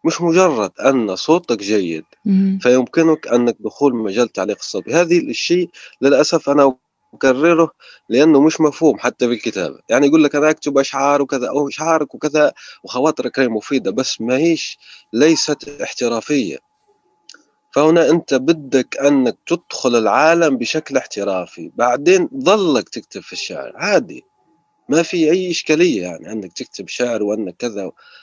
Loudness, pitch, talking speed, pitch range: -16 LUFS, 145 Hz, 135 wpm, 130-165 Hz